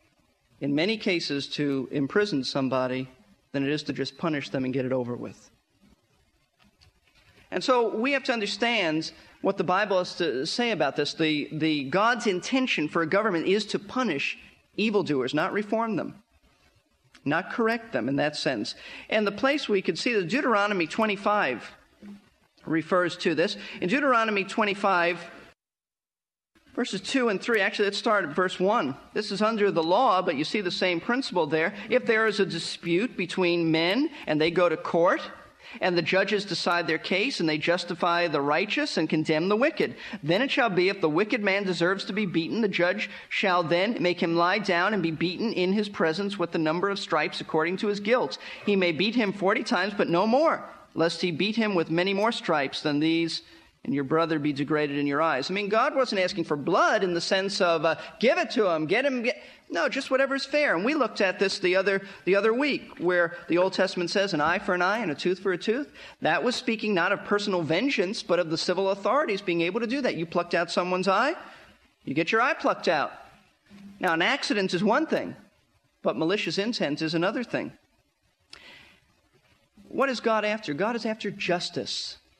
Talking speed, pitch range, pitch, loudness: 200 wpm, 165-220 Hz, 190 Hz, -26 LUFS